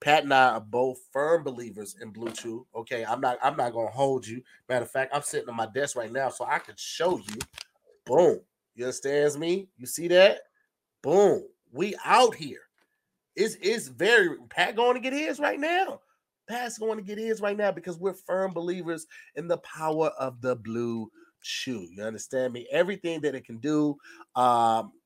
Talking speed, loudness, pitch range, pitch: 195 wpm, -27 LUFS, 125-205 Hz, 150 Hz